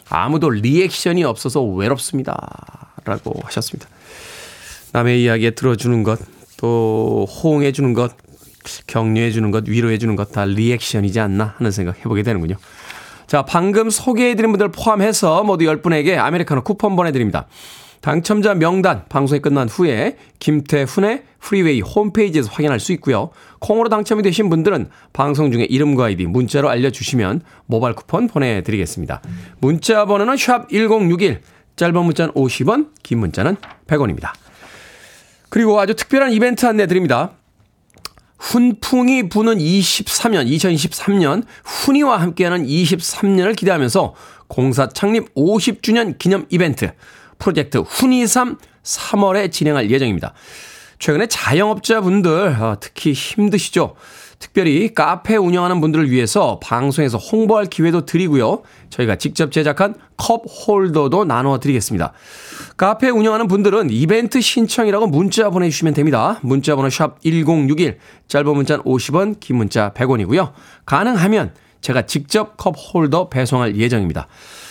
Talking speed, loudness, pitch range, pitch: 315 characters per minute, -16 LUFS, 125-205 Hz, 160 Hz